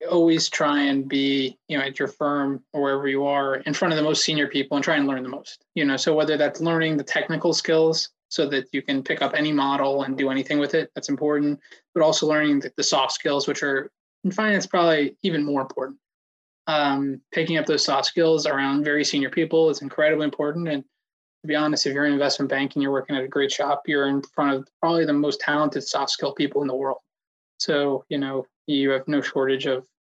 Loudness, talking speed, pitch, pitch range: -23 LUFS, 230 wpm, 145 Hz, 135-155 Hz